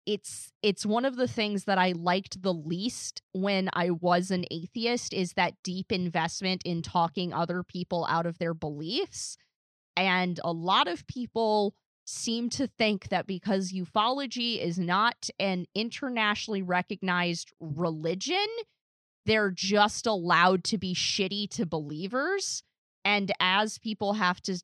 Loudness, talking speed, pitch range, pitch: -29 LUFS, 140 wpm, 175-220 Hz, 190 Hz